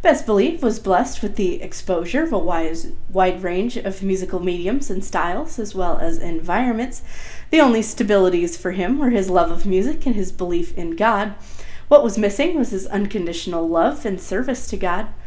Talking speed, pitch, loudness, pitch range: 180 wpm, 195 Hz, -20 LUFS, 180-230 Hz